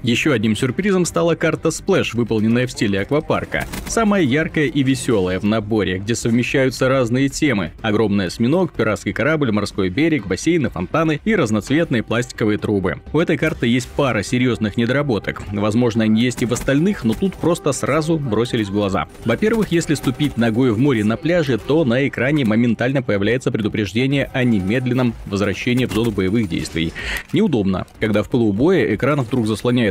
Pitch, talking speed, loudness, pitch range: 120 Hz, 160 wpm, -18 LUFS, 110-145 Hz